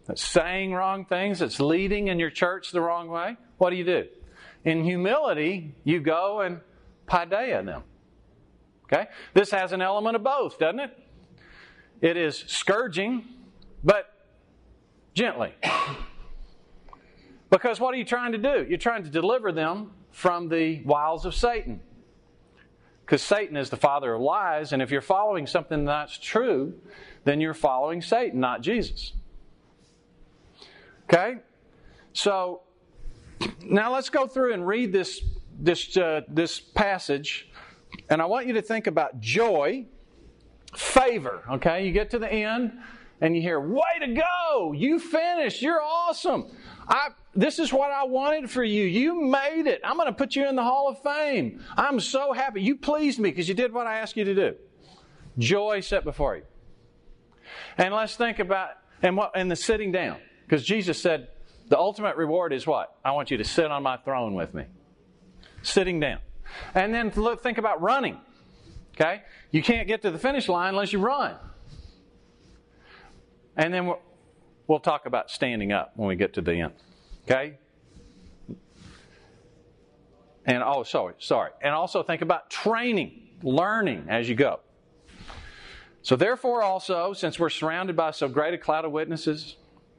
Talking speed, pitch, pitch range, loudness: 160 wpm, 190 Hz, 160-235 Hz, -26 LUFS